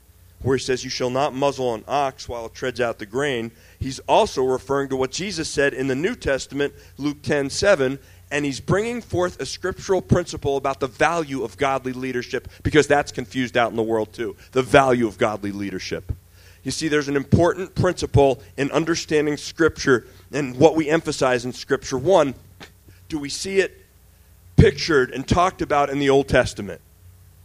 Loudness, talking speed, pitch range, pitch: -22 LUFS, 180 wpm, 110-145 Hz, 130 Hz